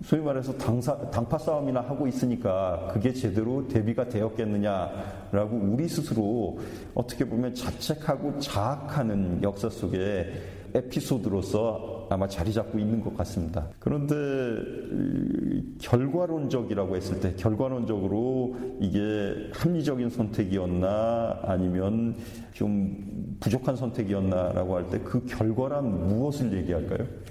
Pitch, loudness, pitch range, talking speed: 115 Hz, -28 LUFS, 100-125 Hz, 290 characters per minute